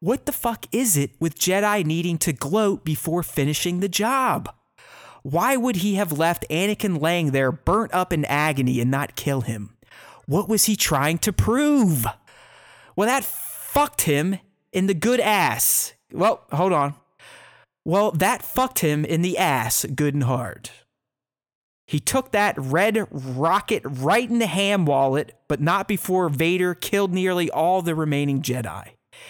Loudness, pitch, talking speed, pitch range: -22 LUFS, 175 Hz, 160 wpm, 145-210 Hz